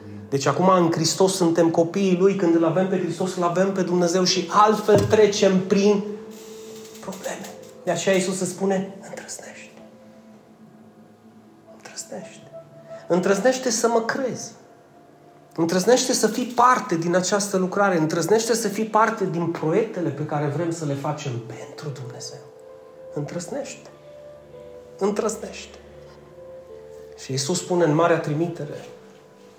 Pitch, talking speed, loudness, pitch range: 185 Hz, 125 wpm, -21 LUFS, 160-215 Hz